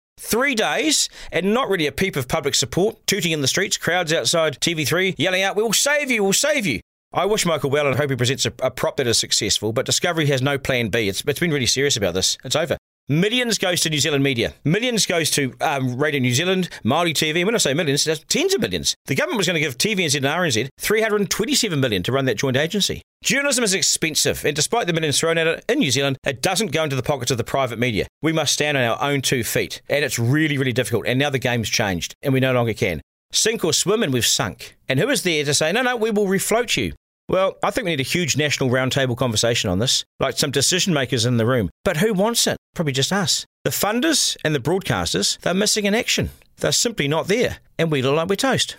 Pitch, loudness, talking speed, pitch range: 150 Hz, -19 LUFS, 255 wpm, 130-190 Hz